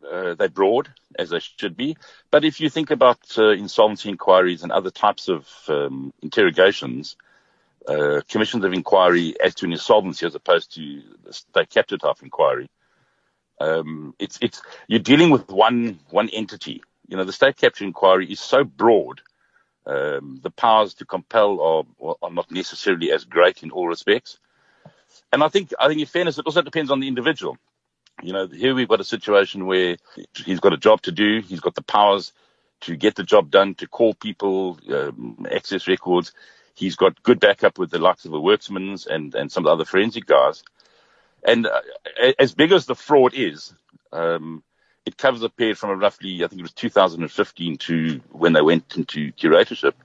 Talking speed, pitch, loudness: 185 wpm, 105 Hz, -20 LUFS